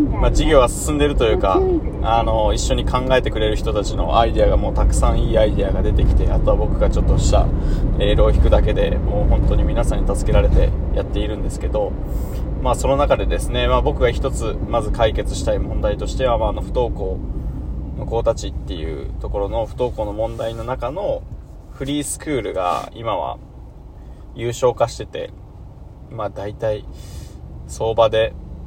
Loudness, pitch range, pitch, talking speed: -20 LUFS, 80-115 Hz, 110 Hz, 365 characters per minute